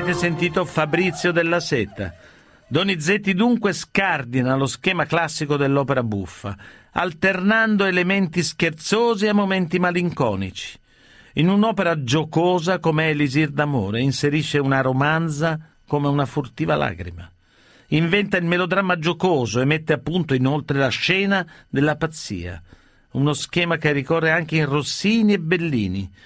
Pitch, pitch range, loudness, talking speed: 160 Hz, 135-180 Hz, -20 LUFS, 125 wpm